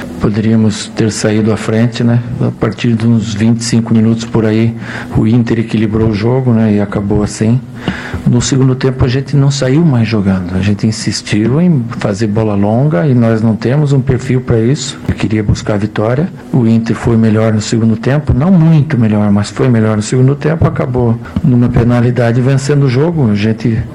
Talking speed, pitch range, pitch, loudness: 190 wpm, 110-130 Hz, 115 Hz, -11 LUFS